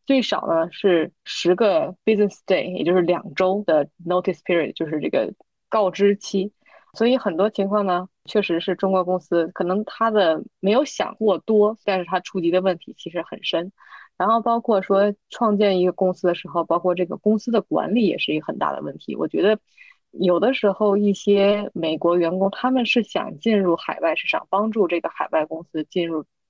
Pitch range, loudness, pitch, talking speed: 175-210 Hz, -21 LUFS, 190 Hz, 320 characters per minute